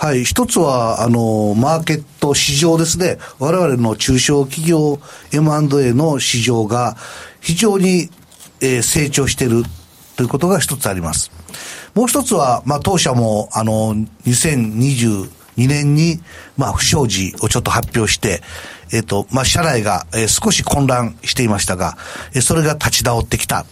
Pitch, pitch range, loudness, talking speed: 130 Hz, 115-155 Hz, -15 LUFS, 275 characters per minute